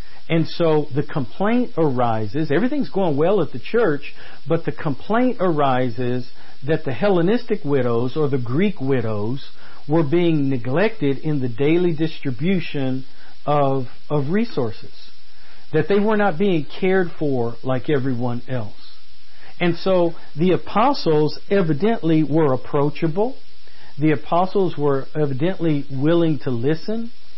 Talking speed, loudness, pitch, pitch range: 125 wpm, -21 LUFS, 155 Hz, 135-180 Hz